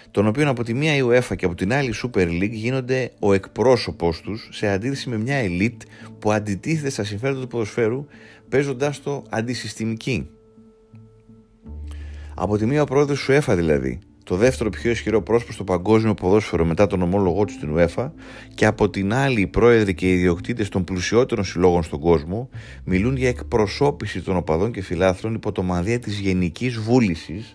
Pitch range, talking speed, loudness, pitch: 95-120 Hz, 175 wpm, -21 LUFS, 110 Hz